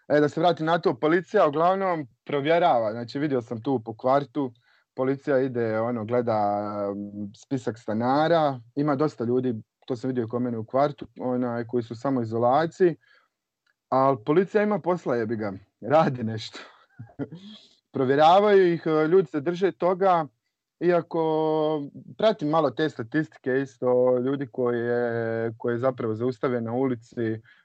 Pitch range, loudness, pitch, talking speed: 120-155 Hz, -25 LUFS, 135 Hz, 135 wpm